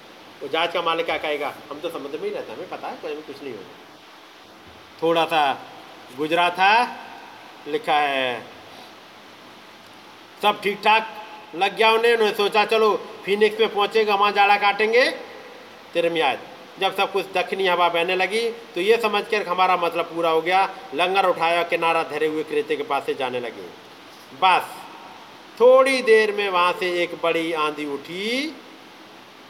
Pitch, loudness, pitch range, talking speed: 200 Hz, -21 LUFS, 170-220 Hz, 160 wpm